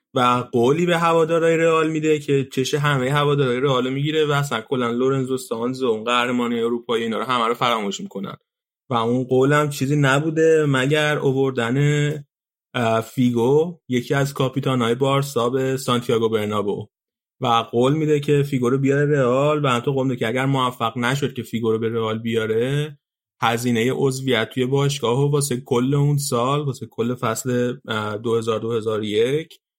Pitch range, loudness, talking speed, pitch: 120-145 Hz, -20 LUFS, 160 wpm, 130 Hz